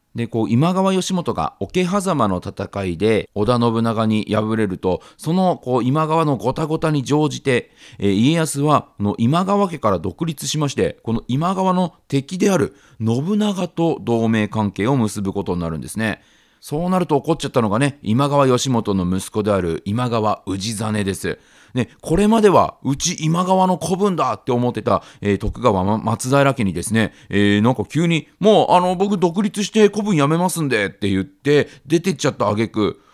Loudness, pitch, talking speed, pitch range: -19 LUFS, 130 Hz, 285 characters per minute, 105-170 Hz